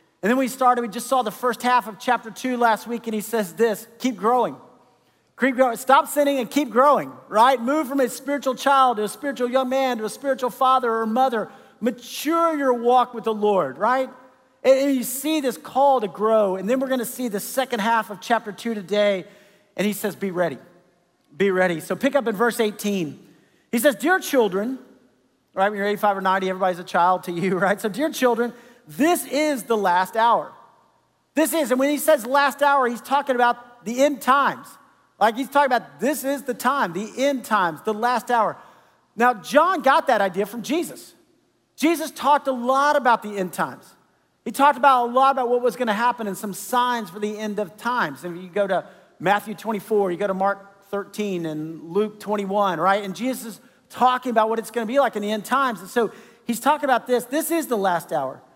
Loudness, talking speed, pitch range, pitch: -21 LUFS, 215 wpm, 205-265 Hz, 240 Hz